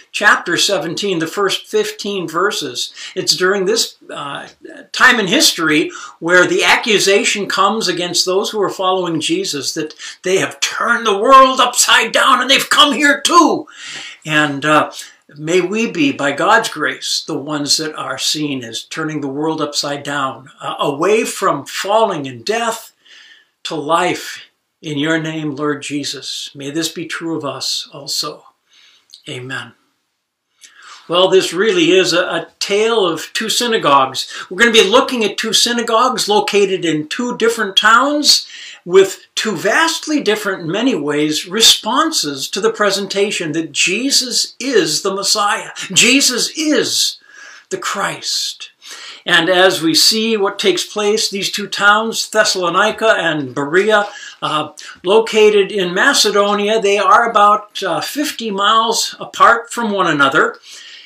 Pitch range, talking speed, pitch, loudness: 170-245 Hz, 145 wpm, 205 Hz, -14 LUFS